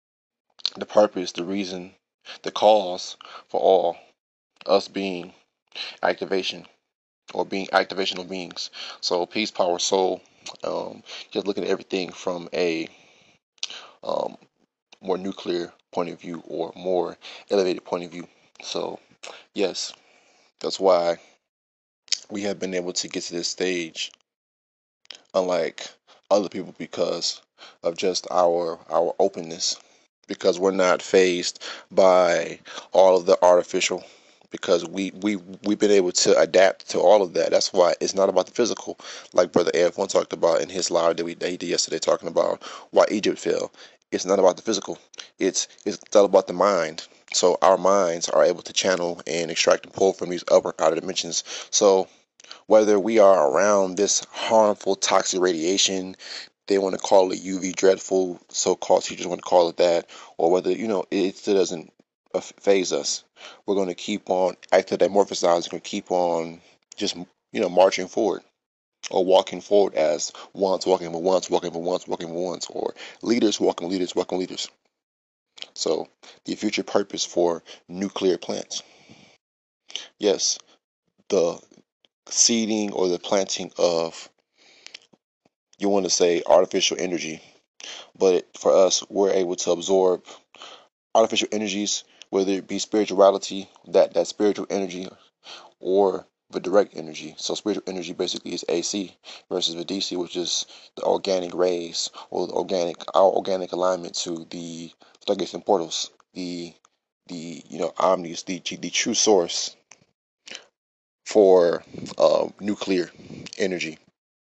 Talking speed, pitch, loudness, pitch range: 150 wpm, 90 Hz, -23 LUFS, 85-100 Hz